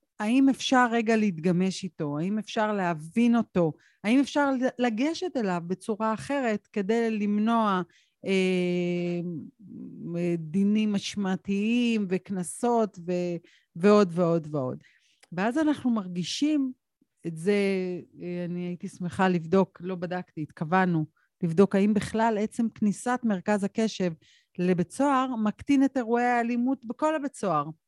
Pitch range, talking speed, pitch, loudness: 180-235 Hz, 110 wpm, 200 Hz, -27 LUFS